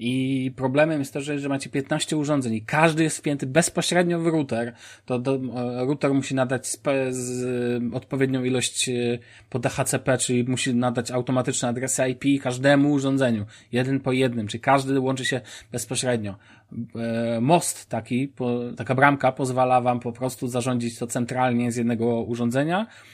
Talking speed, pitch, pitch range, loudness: 135 wpm, 130 Hz, 120-135 Hz, -24 LUFS